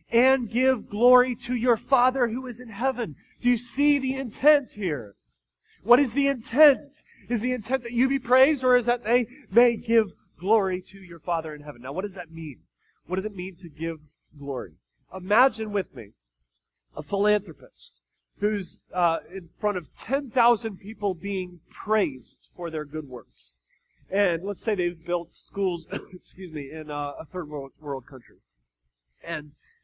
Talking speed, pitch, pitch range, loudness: 175 wpm, 200 Hz, 165-245 Hz, -25 LUFS